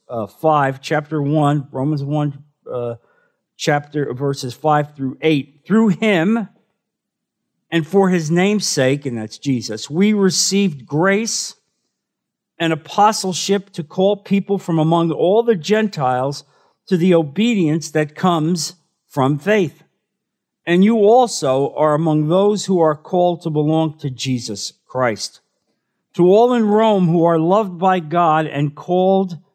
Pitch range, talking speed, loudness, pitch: 145-195 Hz, 135 wpm, -17 LUFS, 165 Hz